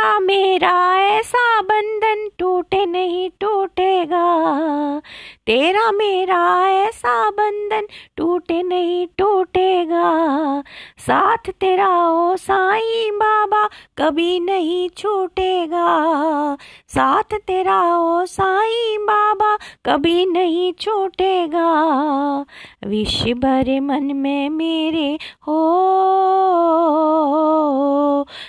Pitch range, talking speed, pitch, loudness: 320-390 Hz, 75 wpm, 360 Hz, -17 LUFS